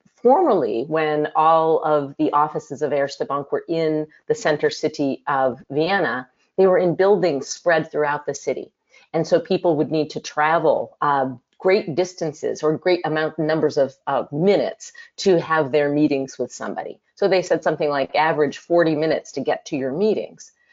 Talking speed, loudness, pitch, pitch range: 175 wpm, -21 LUFS, 155 Hz, 150-170 Hz